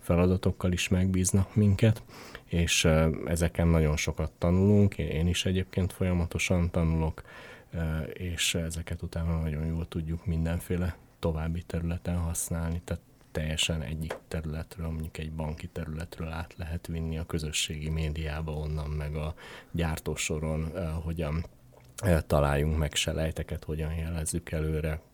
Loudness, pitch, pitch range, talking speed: -30 LUFS, 85 Hz, 80-90 Hz, 115 wpm